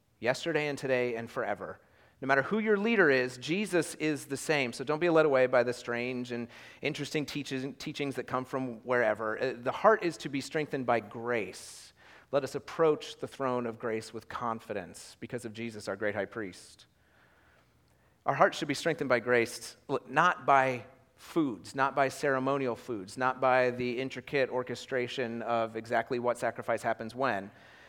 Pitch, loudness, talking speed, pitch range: 130 Hz, -31 LUFS, 170 wpm, 120-140 Hz